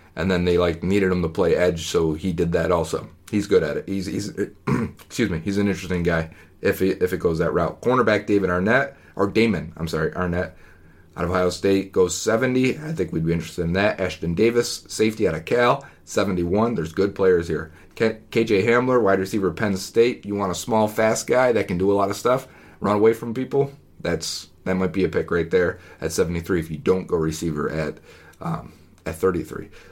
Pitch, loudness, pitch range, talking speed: 95 Hz, -22 LUFS, 85-110 Hz, 215 wpm